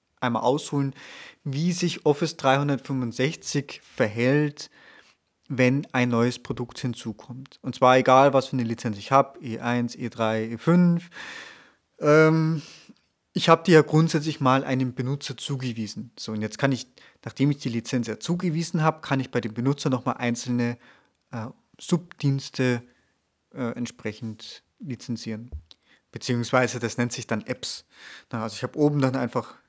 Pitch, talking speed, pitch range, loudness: 130 Hz, 140 wpm, 120-150 Hz, -24 LUFS